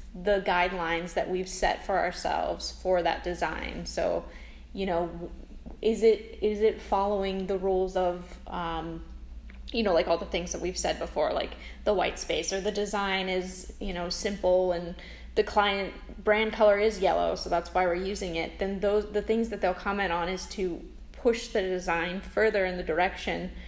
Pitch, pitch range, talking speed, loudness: 185 Hz, 175-205 Hz, 185 wpm, -29 LUFS